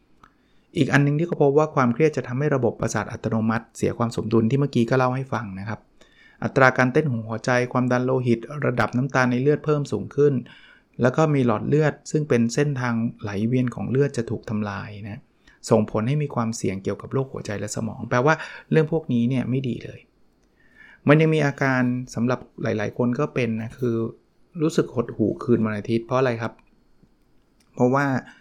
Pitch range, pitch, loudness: 115-140 Hz, 125 Hz, -23 LUFS